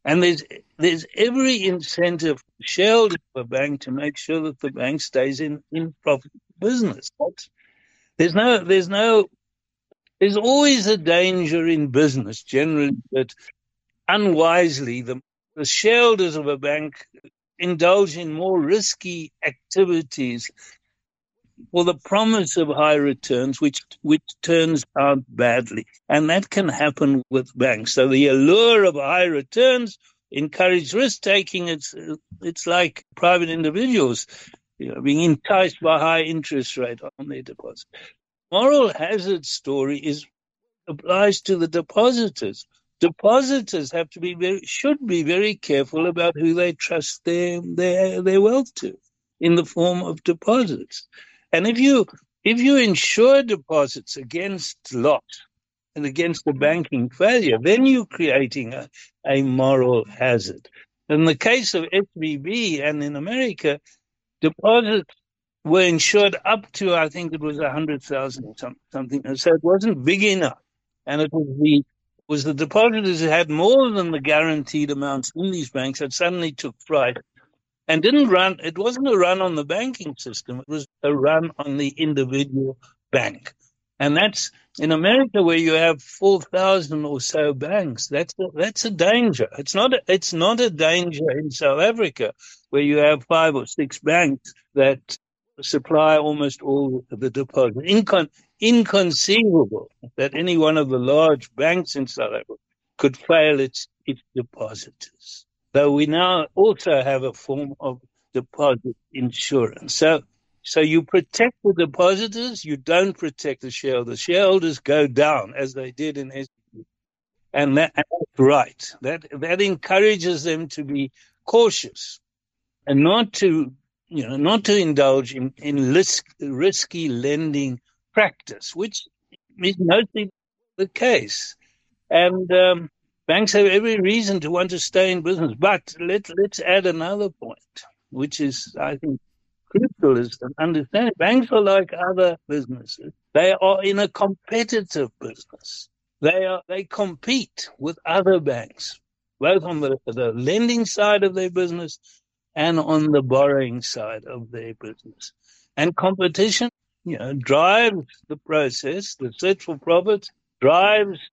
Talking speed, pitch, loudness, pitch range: 145 wpm, 165 Hz, -20 LUFS, 140-195 Hz